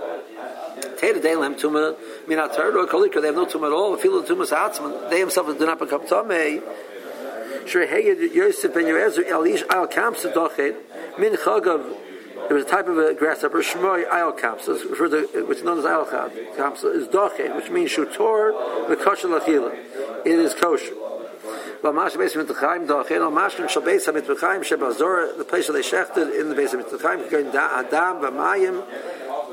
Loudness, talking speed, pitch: -21 LUFS, 200 wpm, 385 Hz